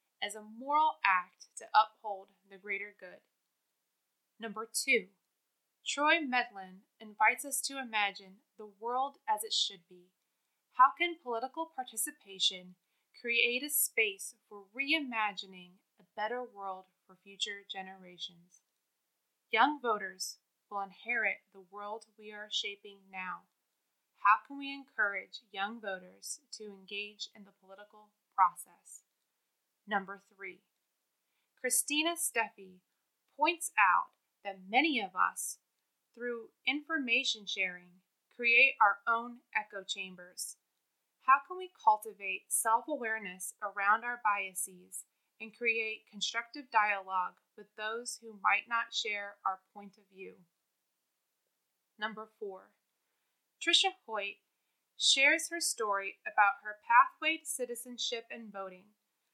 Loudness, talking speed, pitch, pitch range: -32 LUFS, 115 wpm, 215 Hz, 195-255 Hz